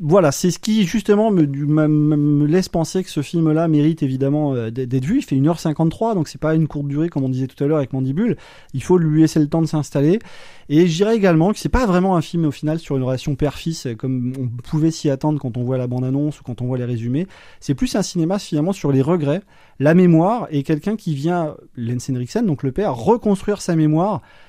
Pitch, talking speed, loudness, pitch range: 155 Hz, 235 wpm, -19 LUFS, 140-180 Hz